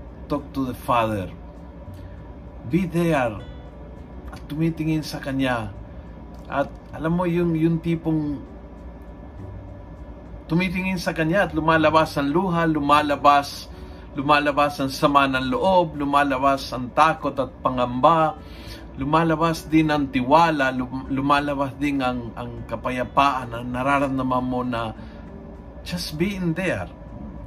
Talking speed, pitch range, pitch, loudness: 110 wpm, 120-160 Hz, 140 Hz, -22 LUFS